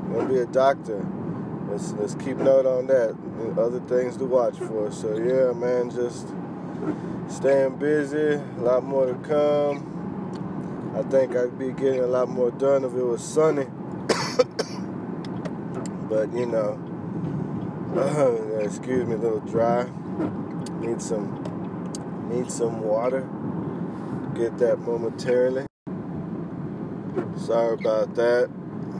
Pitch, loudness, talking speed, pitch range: 135 Hz, -25 LUFS, 120 wpm, 125-160 Hz